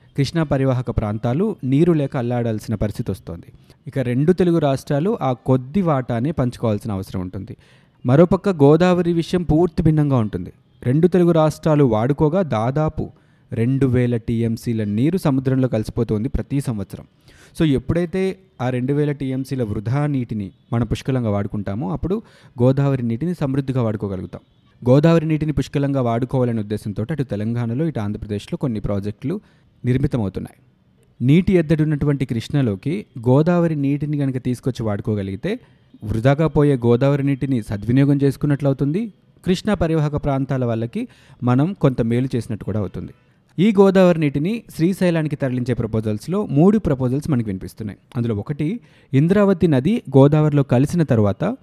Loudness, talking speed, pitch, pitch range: -19 LUFS, 125 wpm, 135 Hz, 115-155 Hz